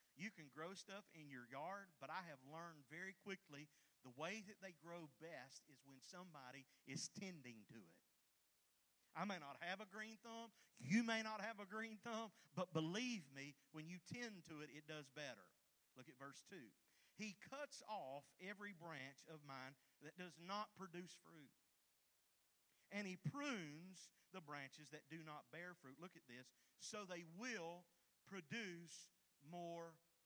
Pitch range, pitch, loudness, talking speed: 150-195 Hz, 170 Hz, -53 LUFS, 170 wpm